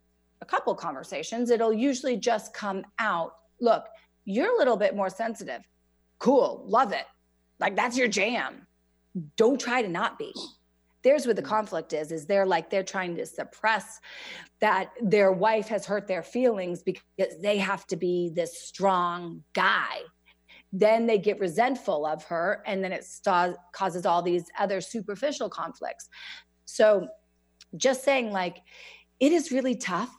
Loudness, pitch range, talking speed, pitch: -27 LUFS, 170-225 Hz, 155 wpm, 195 Hz